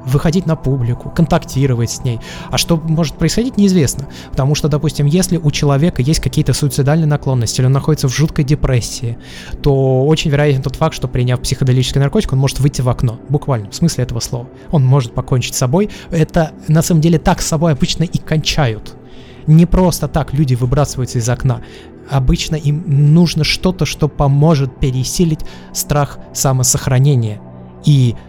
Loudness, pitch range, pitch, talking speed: -15 LUFS, 130-160 Hz, 145 Hz, 165 wpm